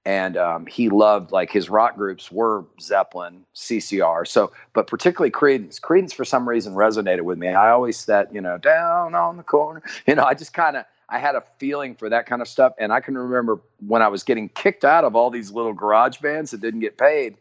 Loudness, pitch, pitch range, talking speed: -20 LUFS, 115 Hz, 105-135 Hz, 230 wpm